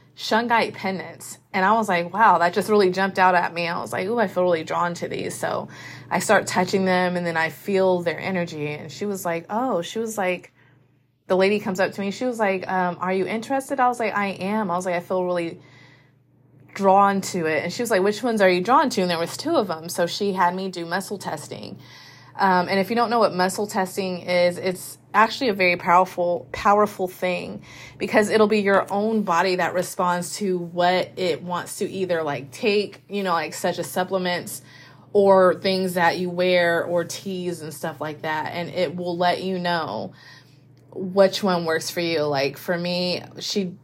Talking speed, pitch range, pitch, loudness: 215 wpm, 170-195 Hz, 180 Hz, -22 LUFS